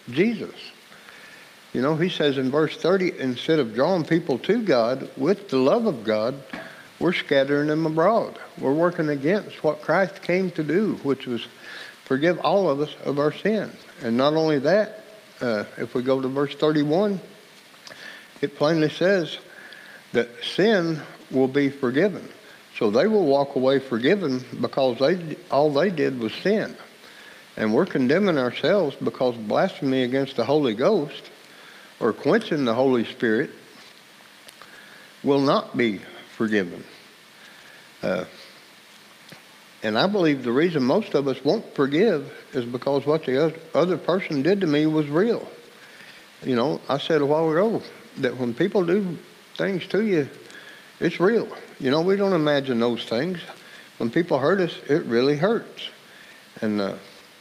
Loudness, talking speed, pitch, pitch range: -23 LUFS, 150 wpm, 150 Hz, 130-180 Hz